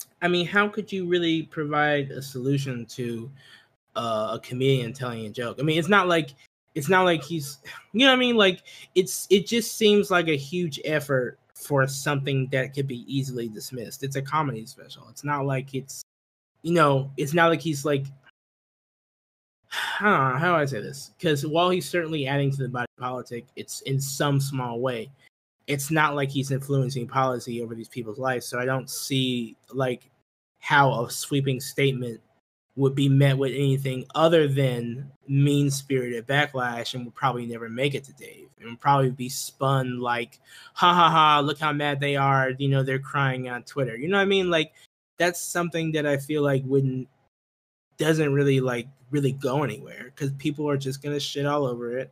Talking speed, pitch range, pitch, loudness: 190 wpm, 130-150 Hz, 135 Hz, -24 LUFS